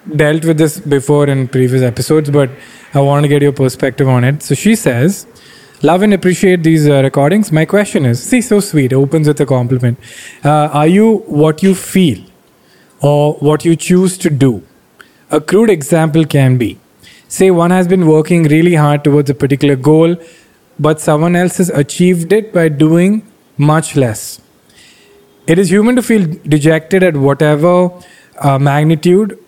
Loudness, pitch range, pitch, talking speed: -11 LUFS, 140-180 Hz, 155 Hz, 170 wpm